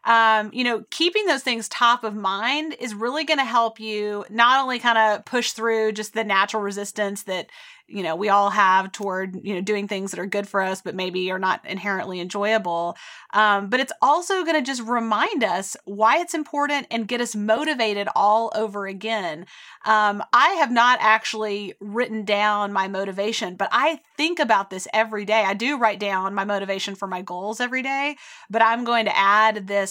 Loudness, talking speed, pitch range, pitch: -22 LUFS, 200 wpm, 200-240 Hz, 215 Hz